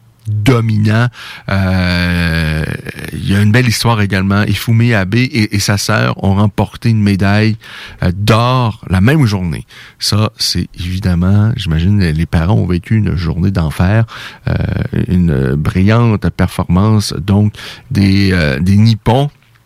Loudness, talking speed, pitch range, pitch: -13 LUFS, 130 wpm, 95-115 Hz, 100 Hz